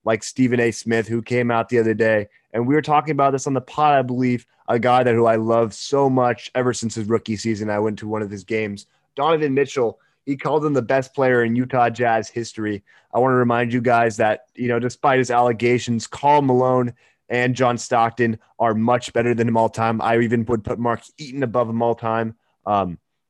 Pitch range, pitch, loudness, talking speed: 115-125 Hz, 120 Hz, -20 LUFS, 225 wpm